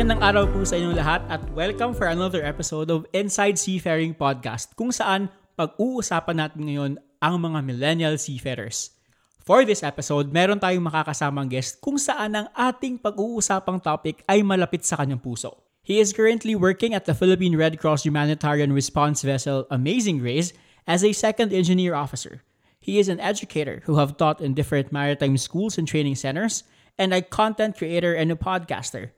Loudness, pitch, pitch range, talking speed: -23 LUFS, 165 Hz, 145-195 Hz, 170 wpm